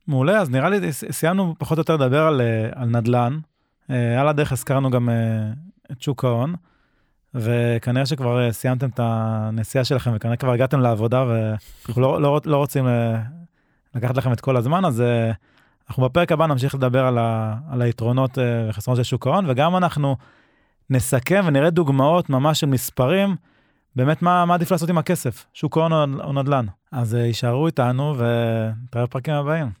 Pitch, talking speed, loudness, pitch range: 130 Hz, 155 wpm, -20 LUFS, 120-150 Hz